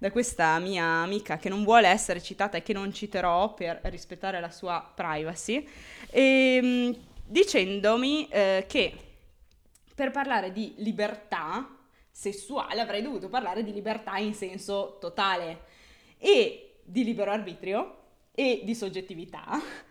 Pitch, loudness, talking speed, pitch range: 205 Hz, -28 LUFS, 125 wpm, 185-245 Hz